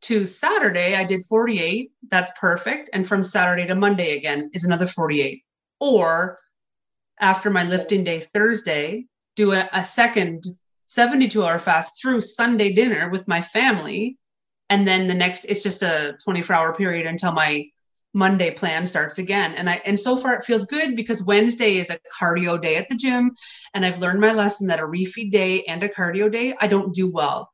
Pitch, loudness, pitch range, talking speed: 190 Hz, -20 LUFS, 175-215 Hz, 185 wpm